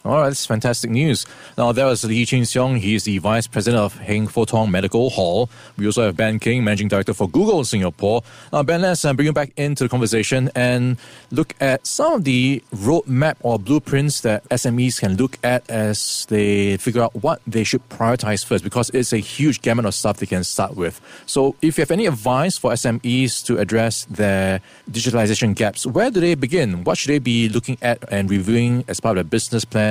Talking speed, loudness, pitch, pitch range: 215 wpm, -19 LUFS, 120 Hz, 105-130 Hz